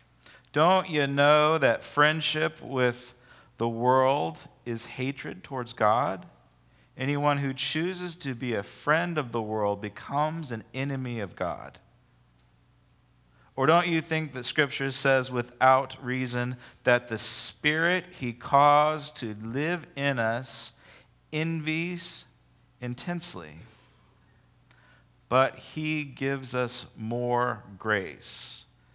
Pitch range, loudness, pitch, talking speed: 120-150 Hz, -27 LUFS, 130 Hz, 110 wpm